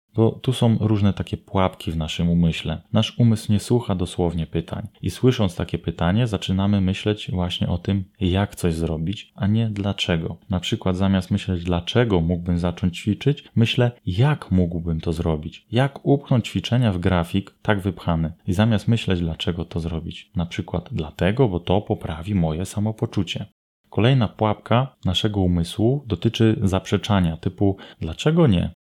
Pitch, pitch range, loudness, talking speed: 100 Hz, 90-110 Hz, -22 LUFS, 150 wpm